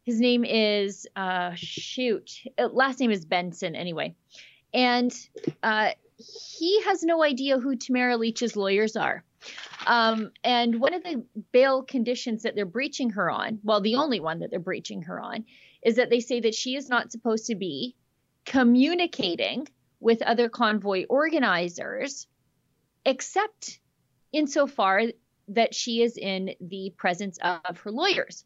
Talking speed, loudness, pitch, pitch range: 150 wpm, -26 LUFS, 235 Hz, 200-260 Hz